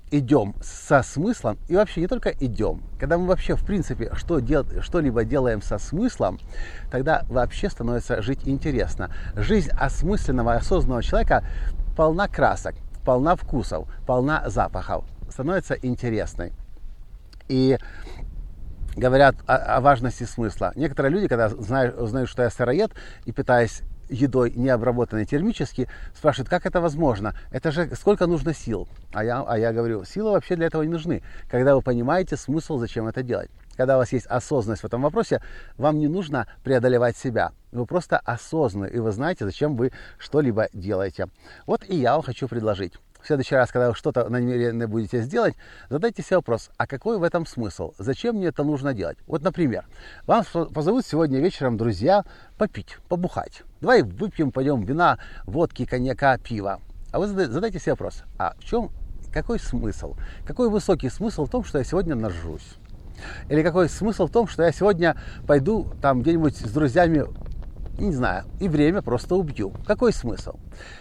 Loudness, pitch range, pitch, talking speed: -24 LUFS, 115-165 Hz, 130 Hz, 160 wpm